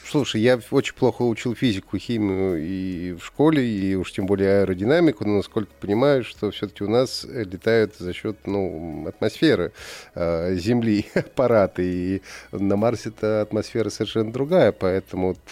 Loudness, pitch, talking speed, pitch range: -23 LUFS, 105 Hz, 145 wpm, 95-120 Hz